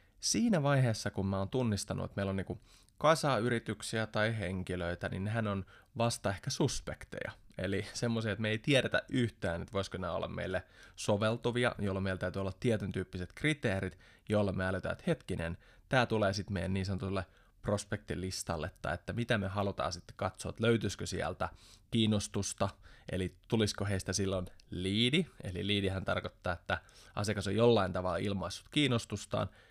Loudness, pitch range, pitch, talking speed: -34 LUFS, 95-115 Hz, 100 Hz, 155 wpm